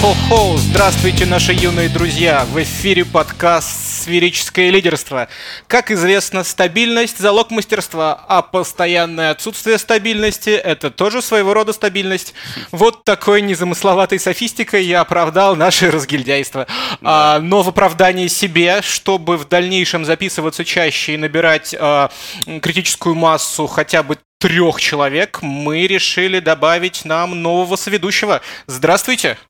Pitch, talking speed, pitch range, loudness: 180 Hz, 115 wpm, 160-200 Hz, -14 LUFS